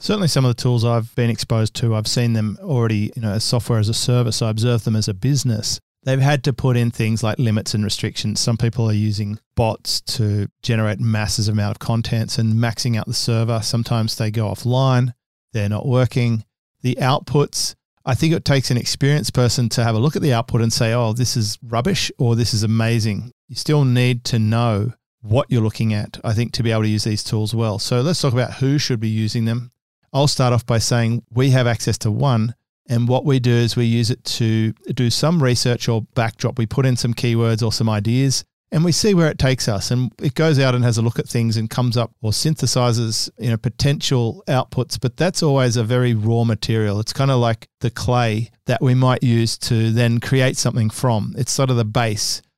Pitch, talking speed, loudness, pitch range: 120 Hz, 225 wpm, -19 LUFS, 110-130 Hz